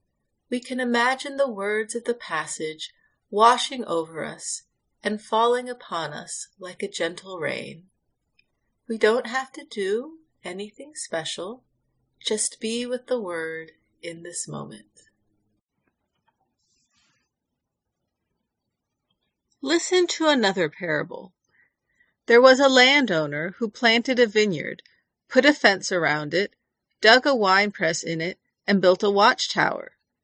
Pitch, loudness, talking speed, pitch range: 220 Hz, -22 LUFS, 125 wpm, 180-255 Hz